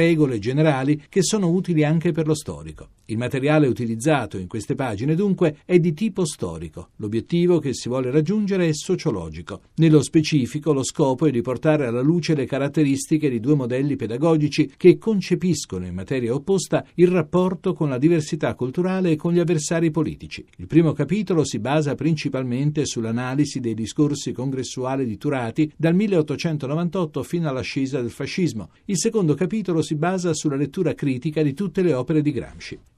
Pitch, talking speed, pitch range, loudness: 150 Hz, 165 wpm, 130-170 Hz, -21 LUFS